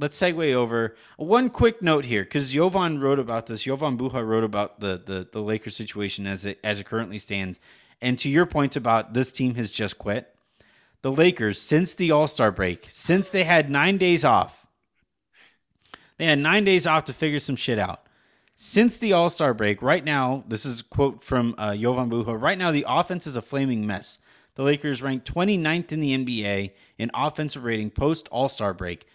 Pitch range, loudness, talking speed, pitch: 110-155 Hz, -23 LUFS, 190 wpm, 130 Hz